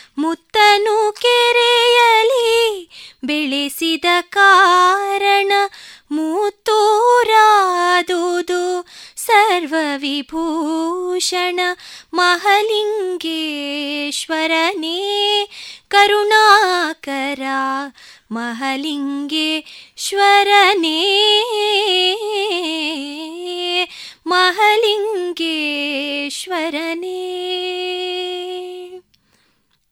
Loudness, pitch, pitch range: -15 LUFS, 360 Hz, 320-410 Hz